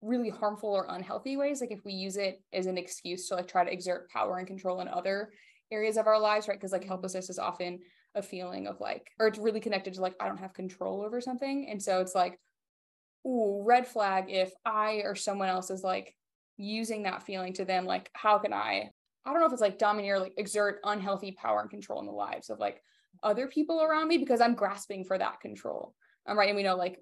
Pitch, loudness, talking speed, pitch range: 200 Hz, -32 LUFS, 240 wpm, 185-215 Hz